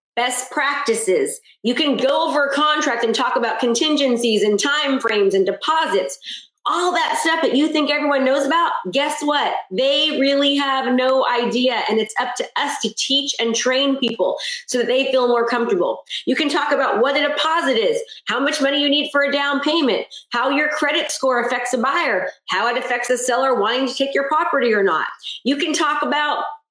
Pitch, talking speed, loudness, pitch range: 280 Hz, 200 wpm, -18 LUFS, 250-300 Hz